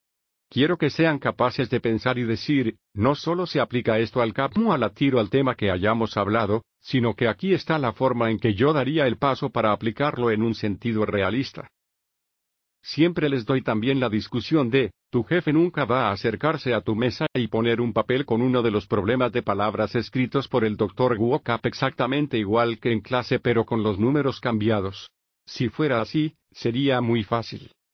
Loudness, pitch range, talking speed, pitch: -23 LUFS, 110-135 Hz, 190 wpm, 120 Hz